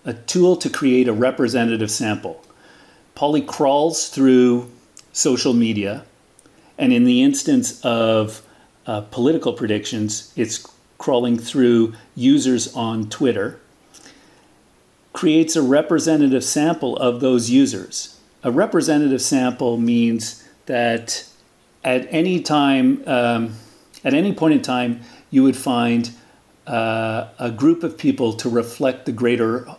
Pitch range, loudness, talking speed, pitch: 115-145 Hz, -19 LUFS, 120 wpm, 125 Hz